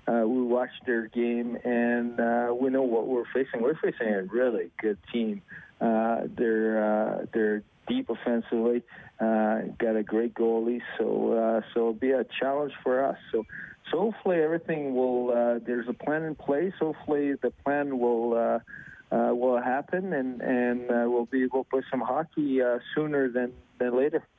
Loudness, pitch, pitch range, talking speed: -28 LUFS, 120 Hz, 115-130 Hz, 175 wpm